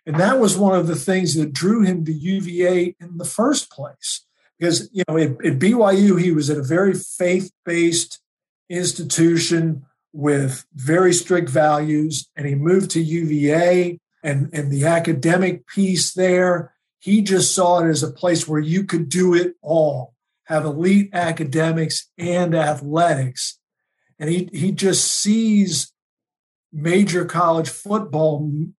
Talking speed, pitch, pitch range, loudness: 150 wpm, 170 Hz, 155-180 Hz, -19 LUFS